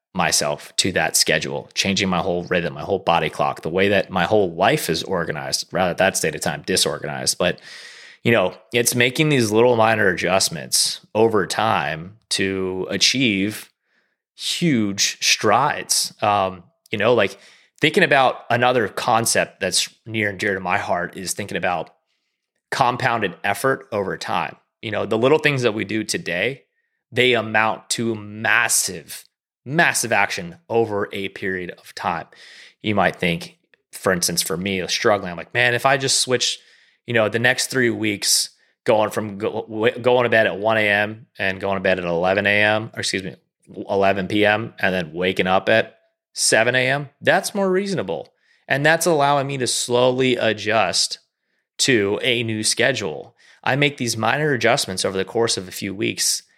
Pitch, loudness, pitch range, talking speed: 110 Hz, -19 LUFS, 100-125 Hz, 170 wpm